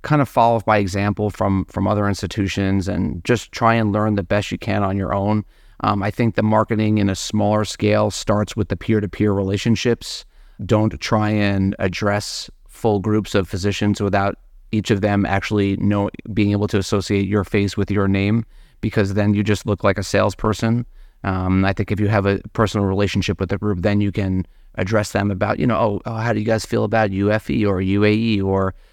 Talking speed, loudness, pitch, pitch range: 205 wpm, -19 LUFS, 105 Hz, 100-110 Hz